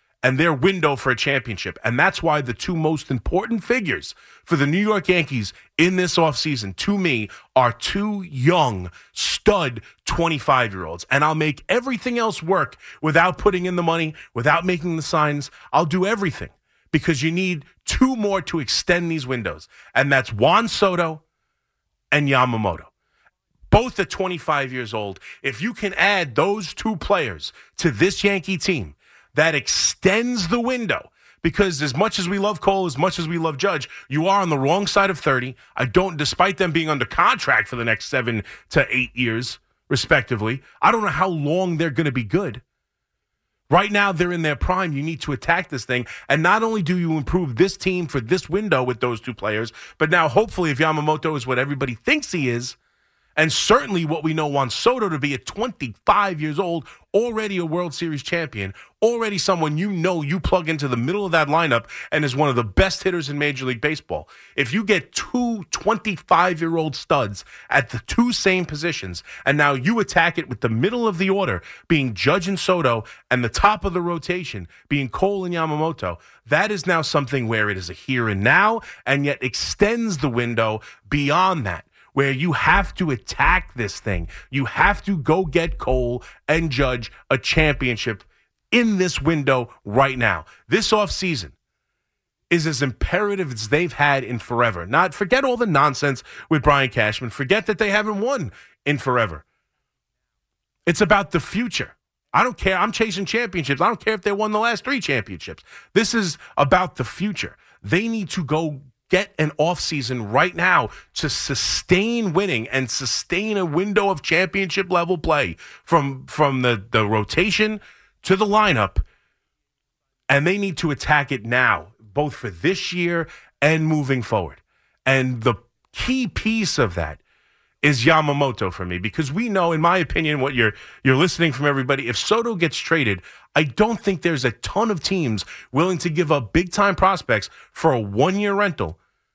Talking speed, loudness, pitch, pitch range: 185 wpm, -20 LUFS, 160 Hz, 130-190 Hz